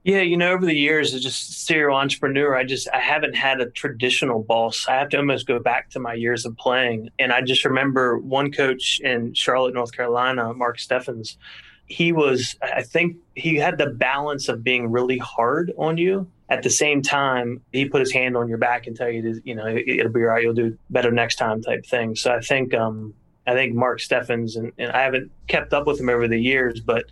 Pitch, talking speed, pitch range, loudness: 125 Hz, 225 wpm, 120-140 Hz, -21 LUFS